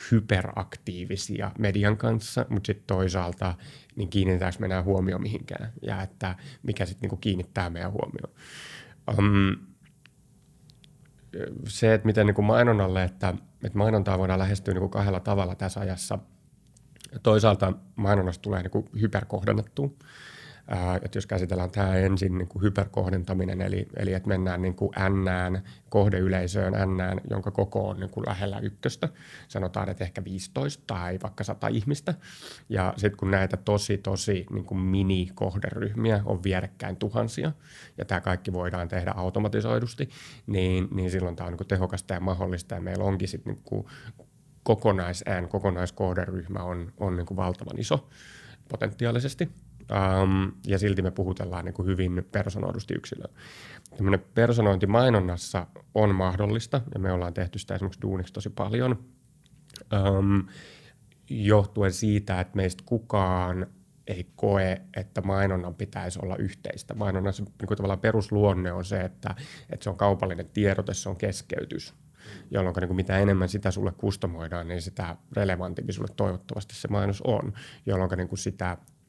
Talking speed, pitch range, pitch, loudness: 140 wpm, 95-110 Hz, 100 Hz, -28 LUFS